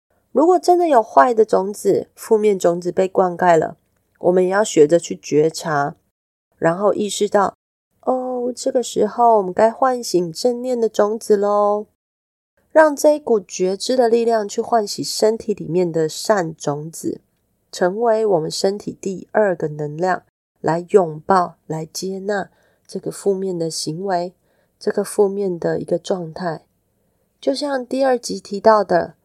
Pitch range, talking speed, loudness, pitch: 175-225 Hz, 220 characters per minute, -18 LUFS, 200 Hz